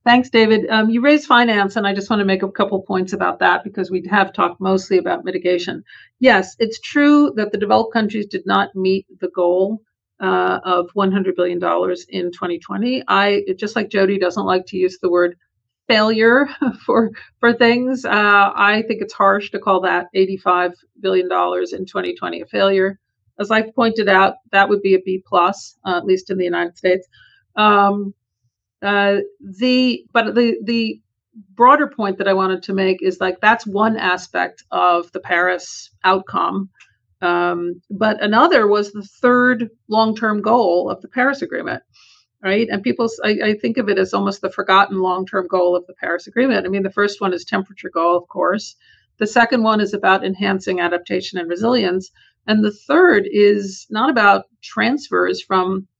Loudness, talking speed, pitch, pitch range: -17 LUFS, 180 wpm, 195 Hz, 185-220 Hz